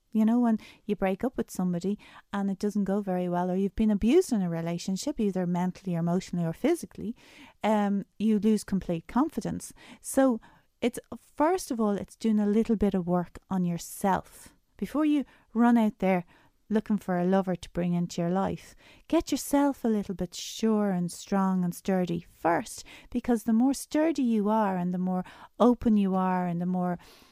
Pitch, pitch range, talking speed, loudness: 205 Hz, 180-230 Hz, 190 wpm, -28 LUFS